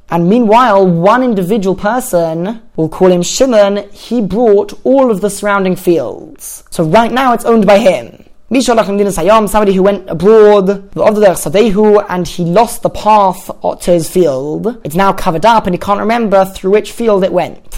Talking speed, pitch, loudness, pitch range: 170 wpm, 205 Hz, -10 LUFS, 185-220 Hz